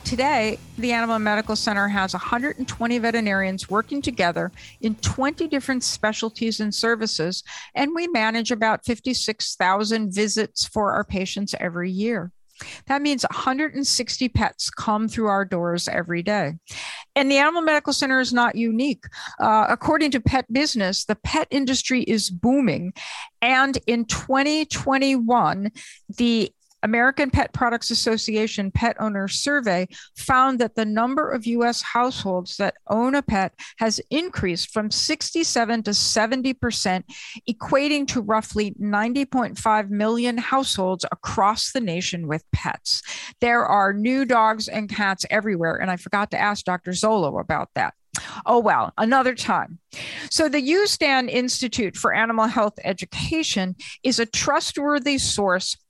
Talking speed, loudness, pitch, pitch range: 135 wpm, -22 LUFS, 230 Hz, 205-265 Hz